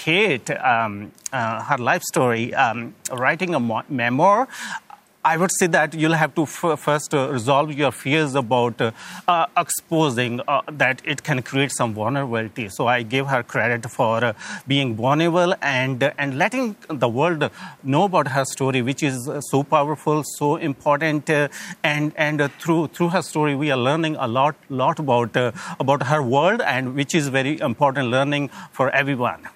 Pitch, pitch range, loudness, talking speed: 140 Hz, 130-155 Hz, -21 LUFS, 180 wpm